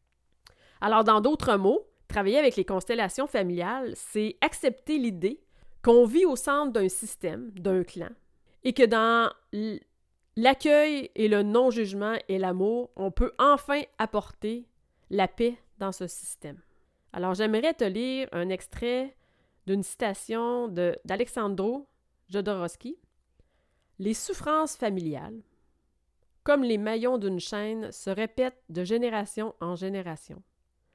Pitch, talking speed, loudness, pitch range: 220 Hz, 120 wpm, -27 LUFS, 195-255 Hz